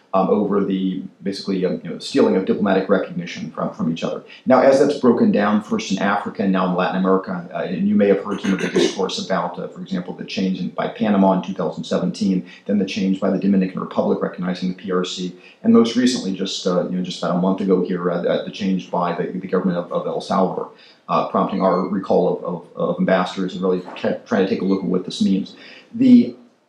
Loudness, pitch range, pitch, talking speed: -20 LUFS, 90-100 Hz, 95 Hz, 235 wpm